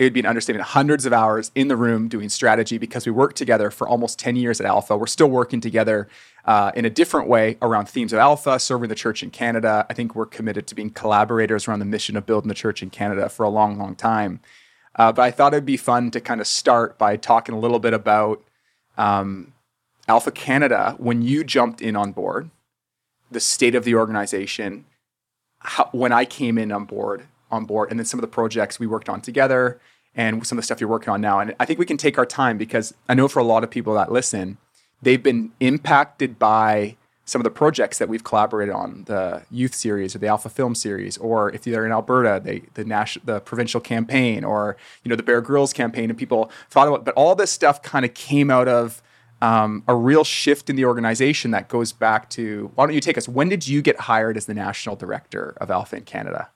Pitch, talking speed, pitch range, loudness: 115 Hz, 230 wpm, 110-125 Hz, -20 LUFS